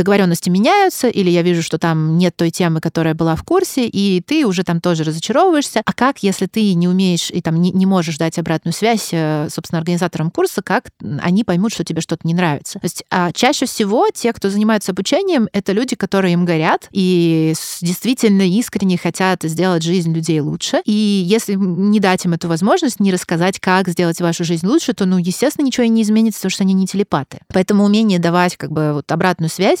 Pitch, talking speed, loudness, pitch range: 185 Hz, 205 wpm, -16 LUFS, 170-215 Hz